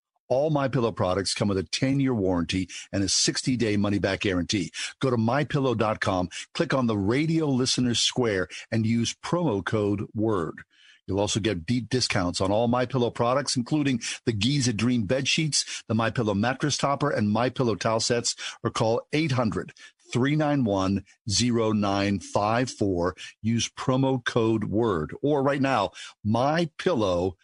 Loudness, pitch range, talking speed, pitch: -25 LUFS, 105-130 Hz, 135 wpm, 115 Hz